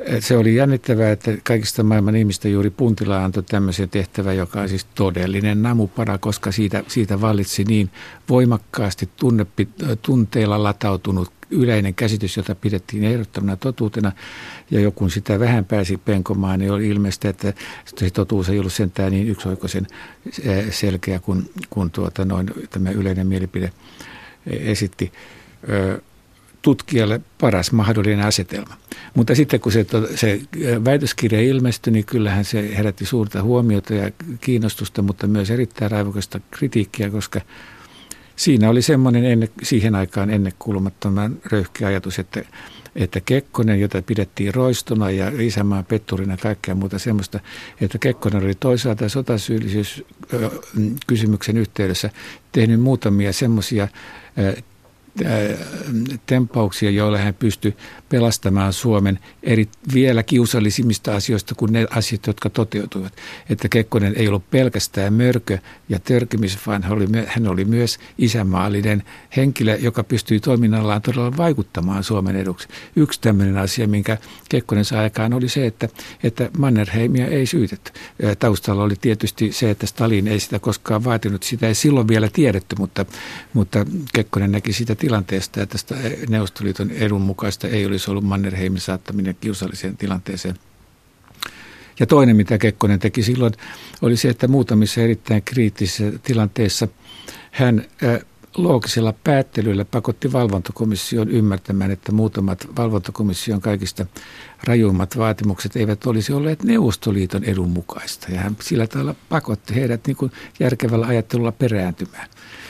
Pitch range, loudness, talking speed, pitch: 100-115 Hz, -19 LUFS, 125 wpm, 105 Hz